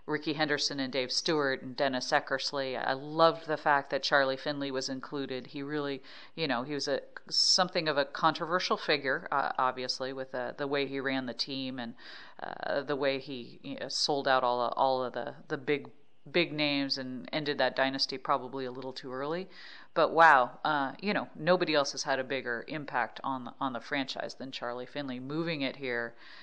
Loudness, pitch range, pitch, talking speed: -31 LUFS, 130-150 Hz, 135 Hz, 200 wpm